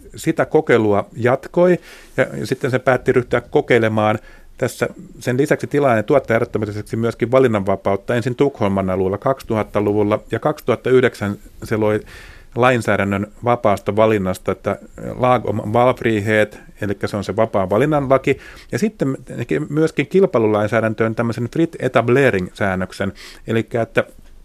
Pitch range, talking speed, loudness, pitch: 105-130 Hz, 115 wpm, -18 LUFS, 115 Hz